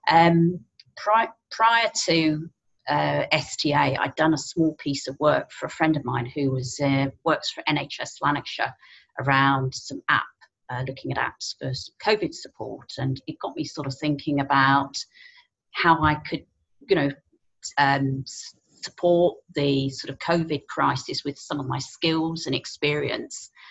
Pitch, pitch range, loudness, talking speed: 145 Hz, 135-165 Hz, -24 LUFS, 155 wpm